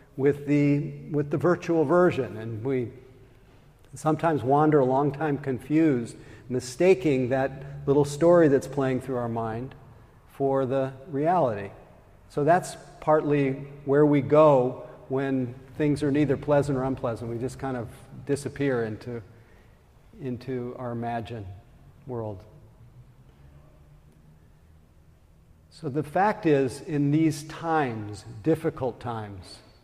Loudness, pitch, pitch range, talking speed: -25 LUFS, 130 Hz, 115-145 Hz, 115 wpm